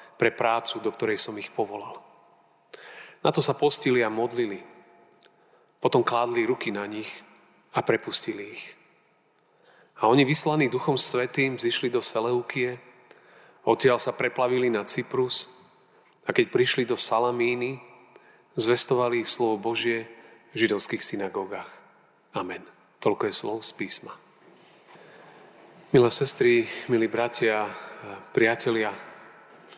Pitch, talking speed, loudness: 125 Hz, 115 wpm, -25 LUFS